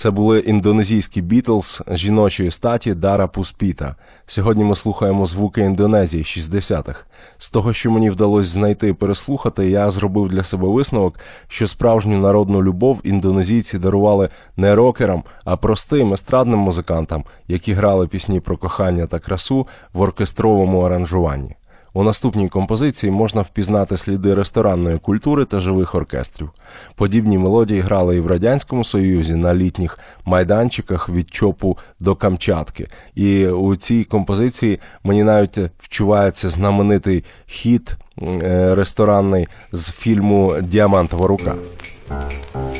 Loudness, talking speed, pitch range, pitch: -17 LUFS, 125 wpm, 90-105 Hz, 100 Hz